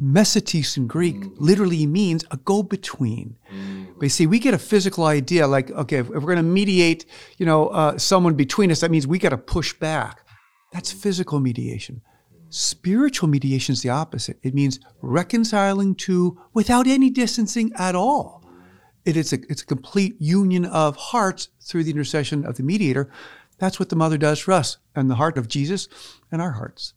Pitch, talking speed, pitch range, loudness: 160 Hz, 185 wpm, 140-190 Hz, -21 LUFS